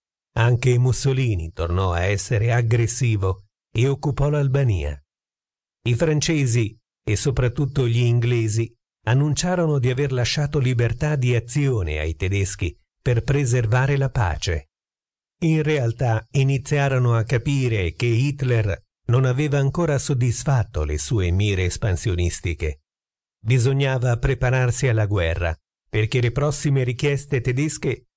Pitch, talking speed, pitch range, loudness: 120 Hz, 110 wpm, 105-135 Hz, -21 LUFS